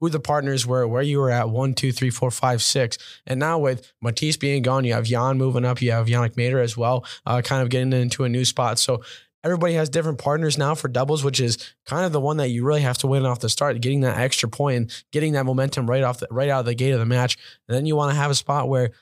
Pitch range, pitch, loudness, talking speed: 125-140 Hz, 130 Hz, -22 LUFS, 285 wpm